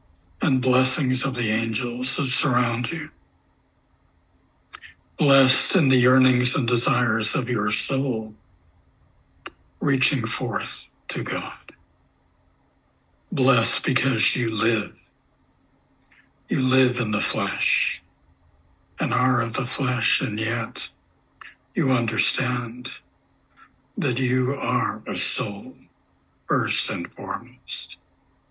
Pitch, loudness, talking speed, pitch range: 120 Hz, -23 LUFS, 100 wpm, 90-130 Hz